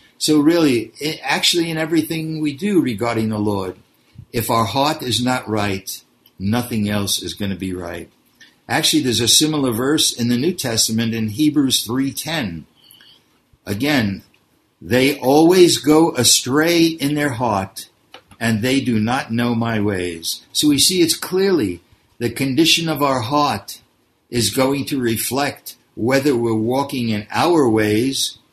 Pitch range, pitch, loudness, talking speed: 110-150 Hz, 125 Hz, -17 LUFS, 150 wpm